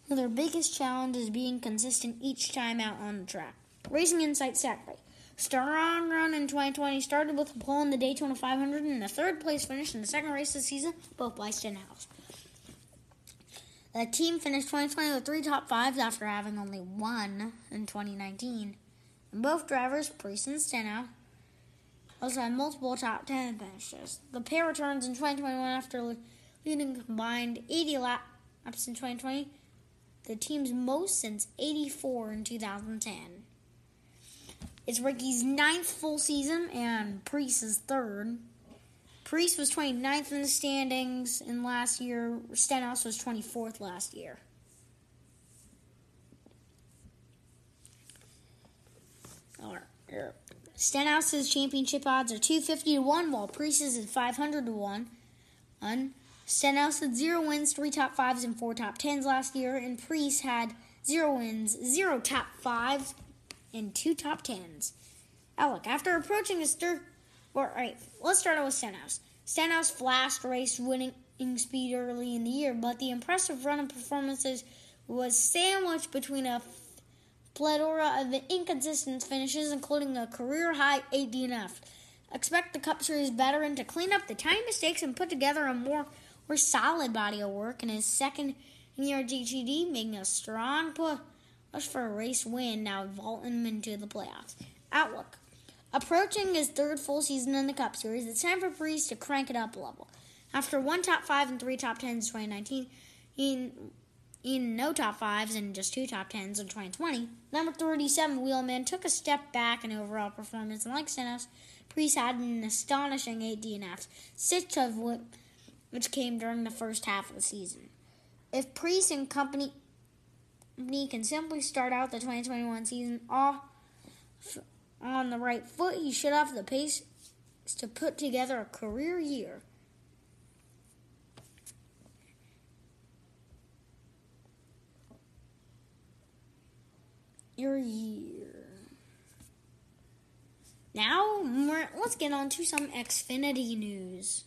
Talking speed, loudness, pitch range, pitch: 145 wpm, -32 LUFS, 235-295 Hz, 265 Hz